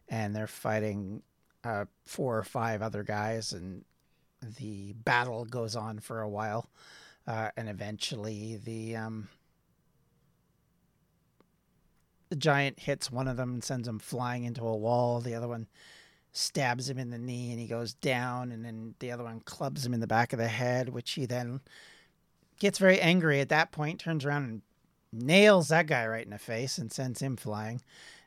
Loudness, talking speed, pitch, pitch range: -31 LUFS, 175 wpm, 120 Hz, 110-135 Hz